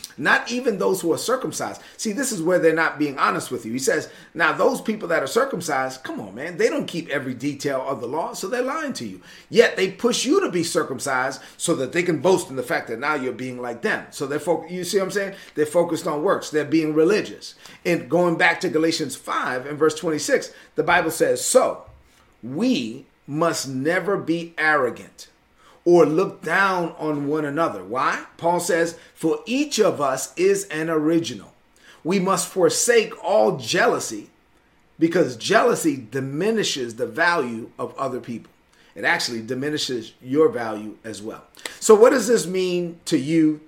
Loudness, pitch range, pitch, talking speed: -22 LUFS, 150-195 Hz, 165 Hz, 190 wpm